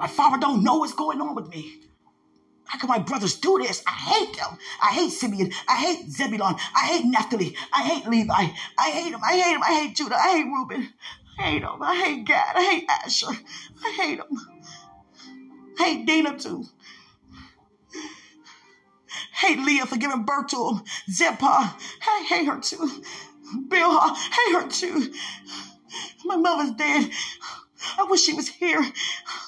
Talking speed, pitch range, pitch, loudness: 170 wpm, 265-350 Hz, 305 Hz, -23 LUFS